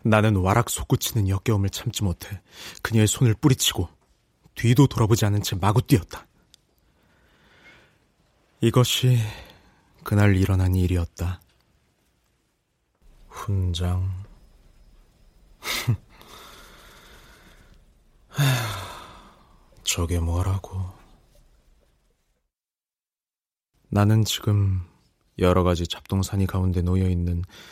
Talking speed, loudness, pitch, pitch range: 170 characters per minute, -23 LUFS, 95 Hz, 90-110 Hz